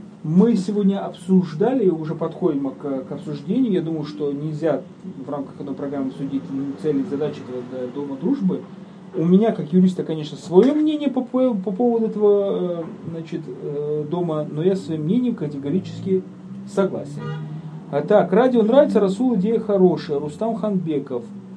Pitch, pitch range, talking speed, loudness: 180 Hz, 150-200 Hz, 140 wpm, -21 LUFS